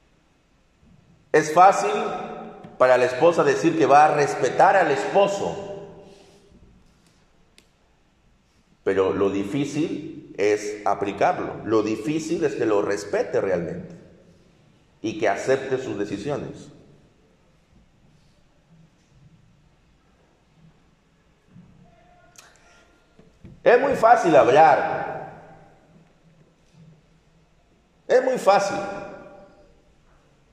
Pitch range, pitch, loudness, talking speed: 150-200 Hz, 165 Hz, -21 LUFS, 70 wpm